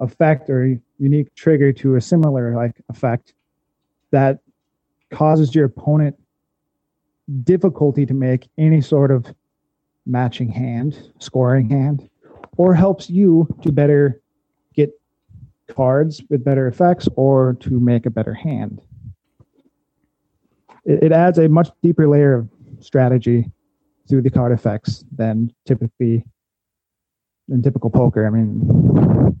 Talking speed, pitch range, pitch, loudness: 120 wpm, 125-150 Hz, 135 Hz, -17 LUFS